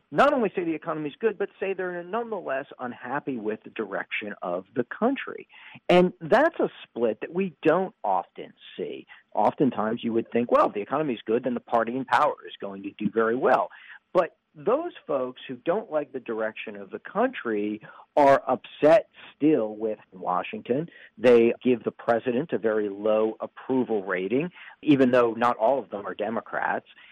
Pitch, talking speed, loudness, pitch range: 130 Hz, 180 wpm, -26 LUFS, 115-195 Hz